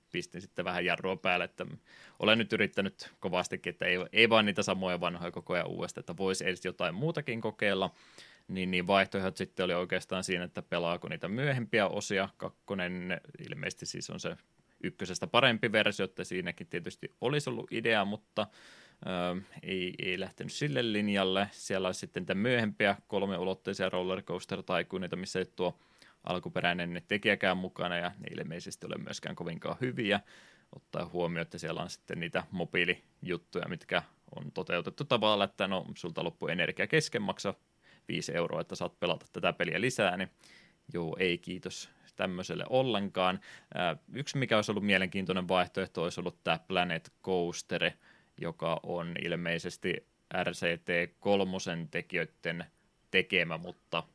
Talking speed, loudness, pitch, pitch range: 145 wpm, -33 LUFS, 95 Hz, 90-100 Hz